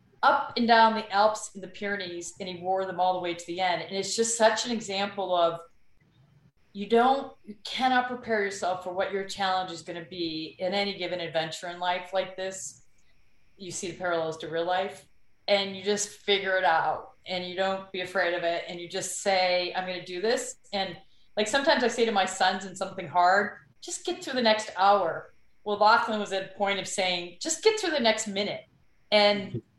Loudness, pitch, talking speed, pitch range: -27 LUFS, 190 Hz, 220 wpm, 180-210 Hz